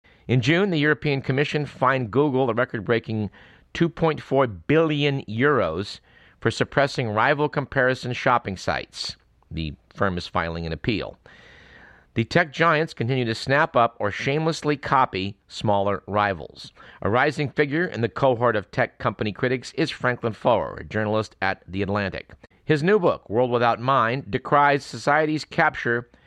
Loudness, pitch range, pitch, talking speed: -23 LUFS, 105-145 Hz, 125 Hz, 145 wpm